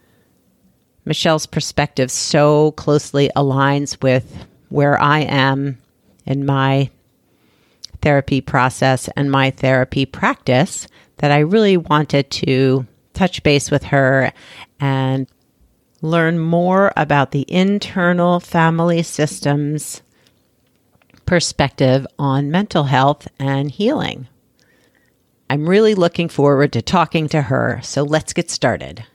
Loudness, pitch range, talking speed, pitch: -16 LUFS, 135-160 Hz, 105 wpm, 140 Hz